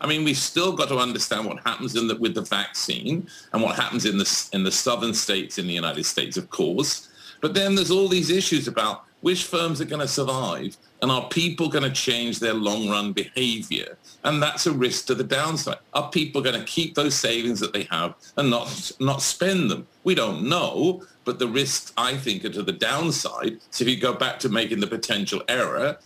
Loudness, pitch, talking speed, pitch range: -23 LUFS, 140 Hz, 220 wpm, 120-170 Hz